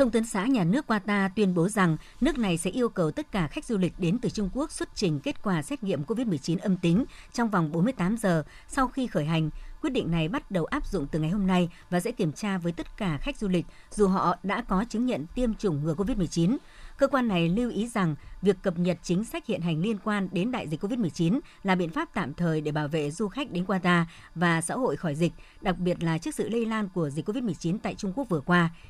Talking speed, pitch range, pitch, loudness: 255 wpm, 170-225 Hz, 190 Hz, -28 LUFS